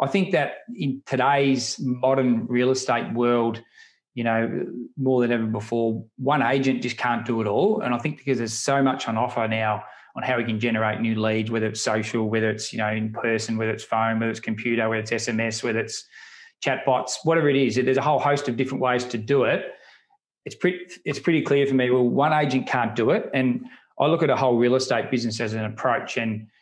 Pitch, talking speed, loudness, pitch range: 120 Hz, 225 wpm, -23 LUFS, 115-135 Hz